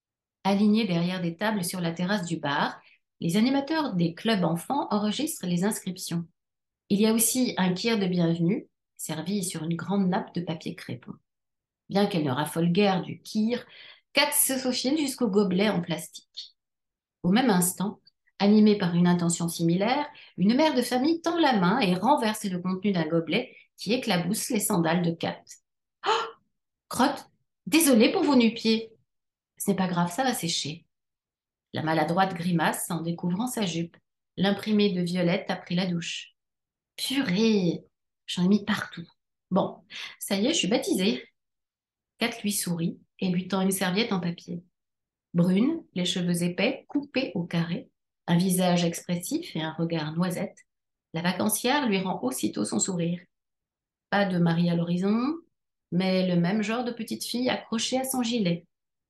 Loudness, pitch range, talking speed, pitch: -26 LUFS, 175-225 Hz, 165 wpm, 190 Hz